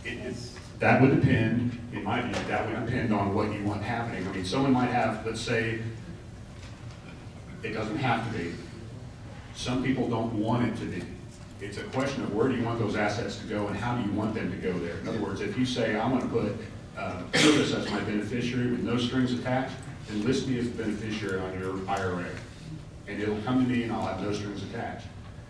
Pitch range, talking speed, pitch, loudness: 105-120 Hz, 225 wpm, 115 Hz, -29 LUFS